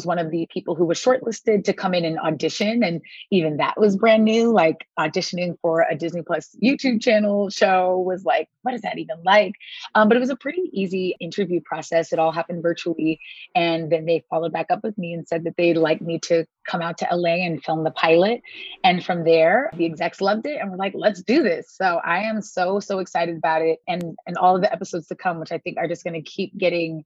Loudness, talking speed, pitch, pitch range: -21 LUFS, 240 wpm, 175 Hz, 165-210 Hz